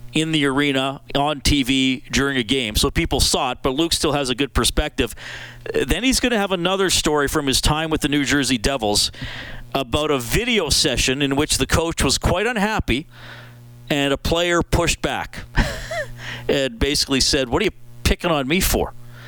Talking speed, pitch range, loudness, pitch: 185 wpm, 130-155 Hz, -19 LUFS, 140 Hz